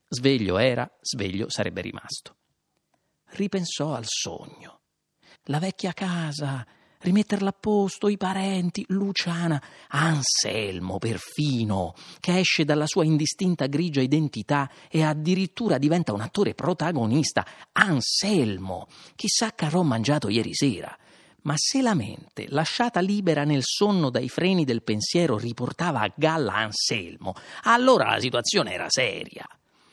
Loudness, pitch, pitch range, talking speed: -24 LUFS, 155 Hz, 135-185 Hz, 120 wpm